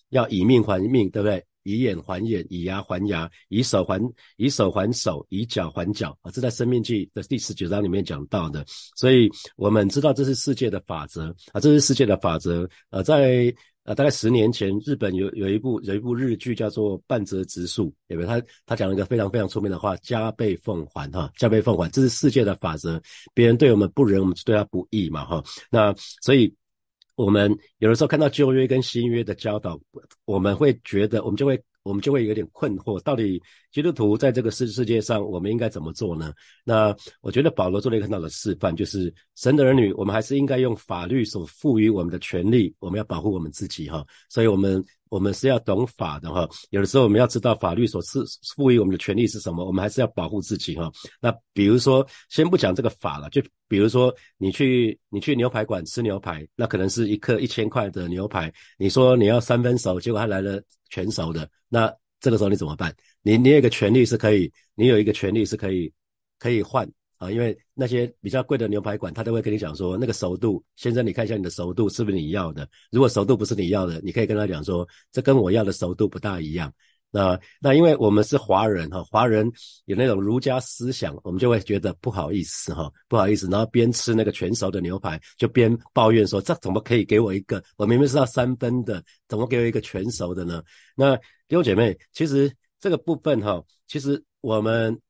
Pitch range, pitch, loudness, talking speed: 95-120 Hz, 110 Hz, -22 LUFS, 335 characters per minute